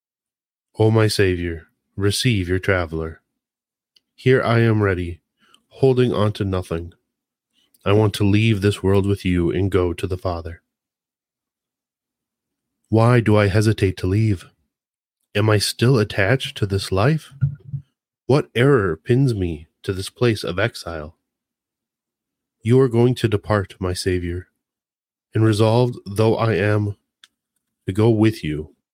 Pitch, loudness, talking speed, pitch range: 105 Hz, -19 LUFS, 135 wpm, 95-115 Hz